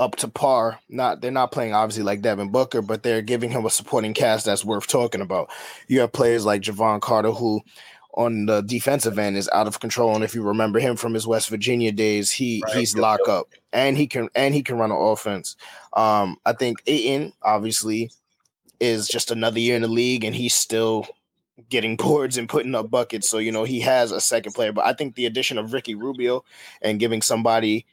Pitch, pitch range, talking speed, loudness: 115 Hz, 110-120 Hz, 215 wpm, -22 LUFS